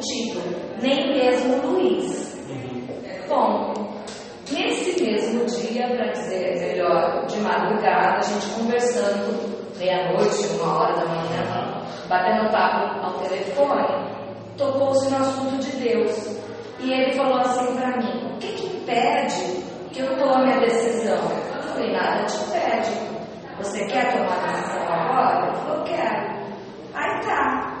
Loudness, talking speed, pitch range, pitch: -23 LUFS, 140 wpm, 220-265 Hz, 245 Hz